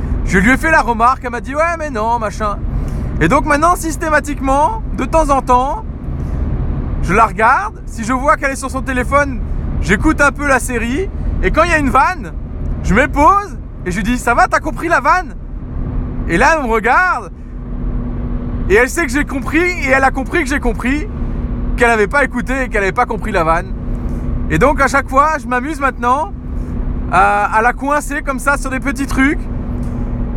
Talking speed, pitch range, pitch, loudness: 205 wpm, 235-295 Hz, 265 Hz, -15 LUFS